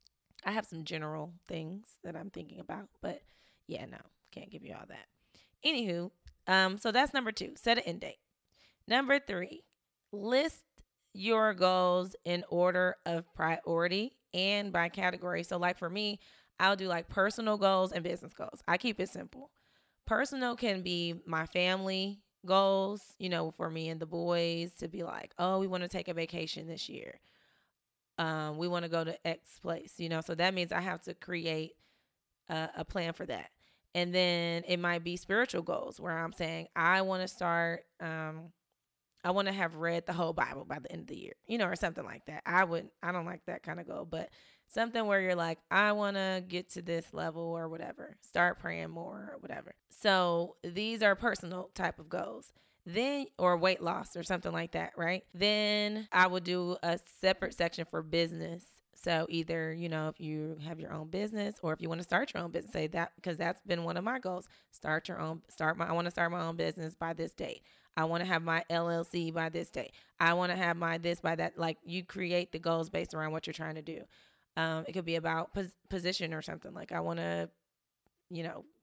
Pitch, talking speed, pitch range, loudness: 175 Hz, 210 wpm, 165-190 Hz, -34 LUFS